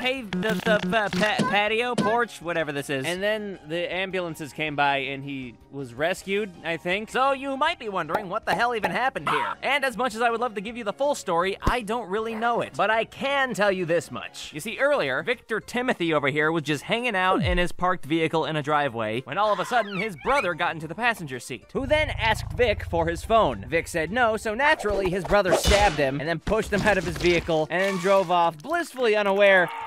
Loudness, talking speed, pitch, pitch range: -24 LUFS, 235 wpm, 195 Hz, 165-230 Hz